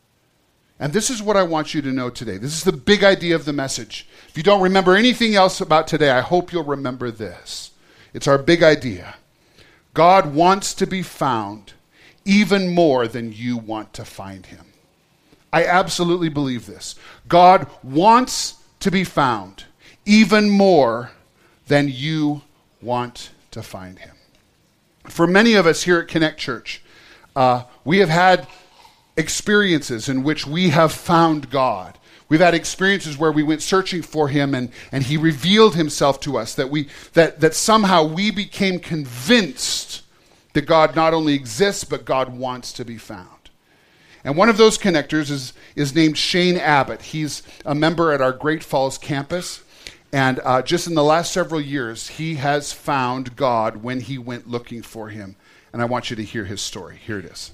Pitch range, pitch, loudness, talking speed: 125-175 Hz, 155 Hz, -18 LUFS, 175 wpm